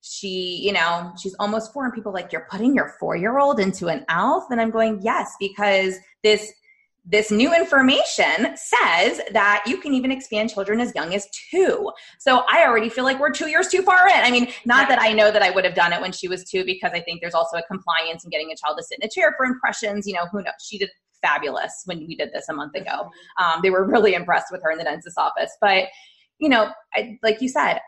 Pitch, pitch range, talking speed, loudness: 210 Hz, 185-265 Hz, 245 wpm, -20 LUFS